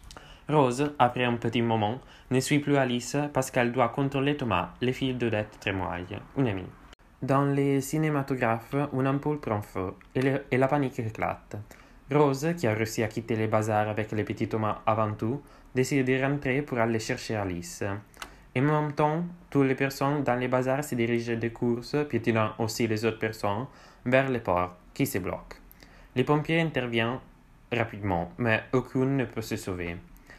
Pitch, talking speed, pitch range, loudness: 120 Hz, 175 wpm, 110-135 Hz, -28 LUFS